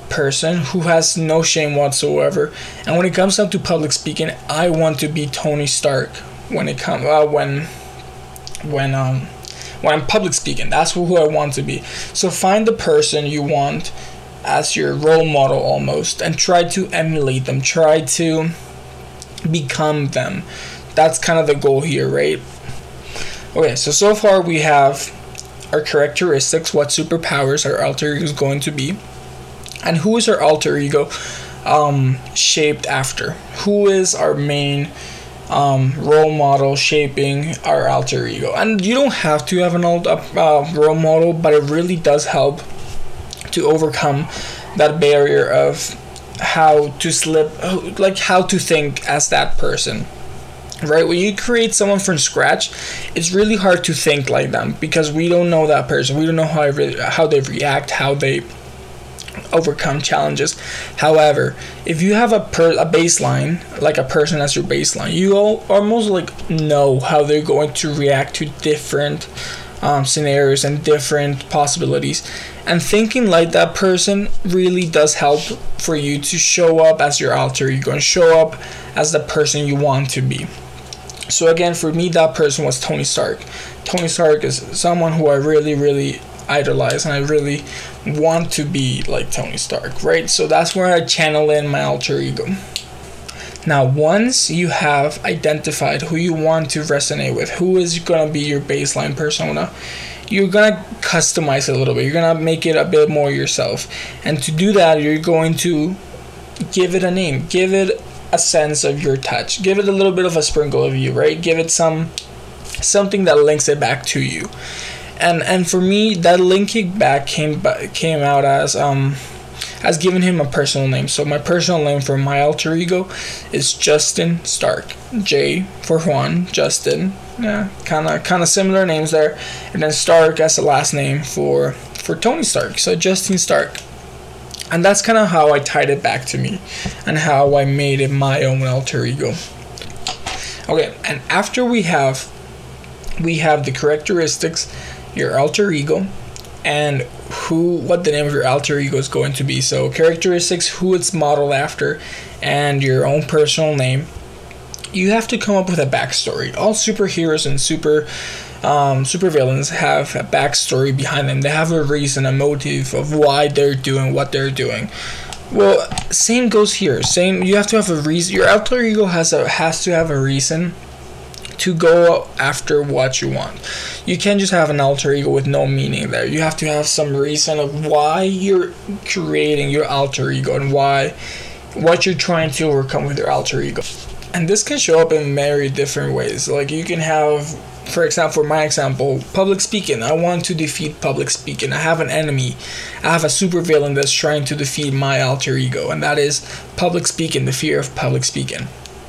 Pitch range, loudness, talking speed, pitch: 135-170 Hz, -16 LUFS, 180 wpm, 150 Hz